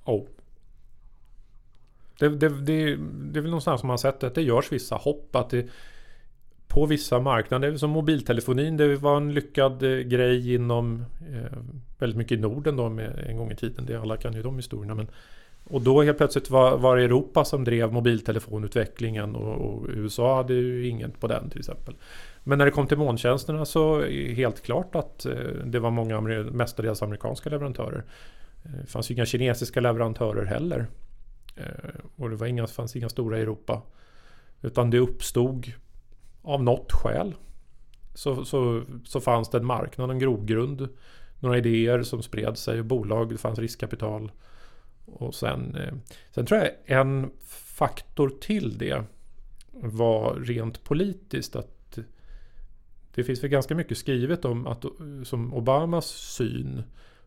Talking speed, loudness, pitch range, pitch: 160 wpm, -26 LUFS, 115-140 Hz, 125 Hz